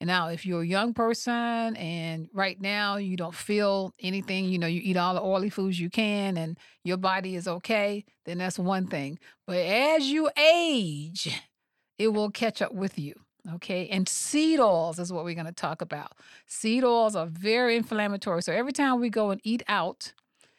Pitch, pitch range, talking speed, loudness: 195 Hz, 175-225 Hz, 190 wpm, -27 LUFS